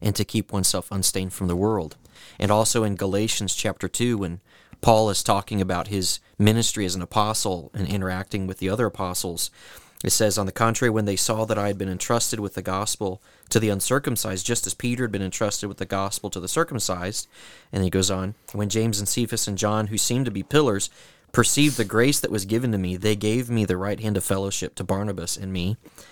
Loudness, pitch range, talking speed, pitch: -24 LUFS, 95-110 Hz, 220 wpm, 100 Hz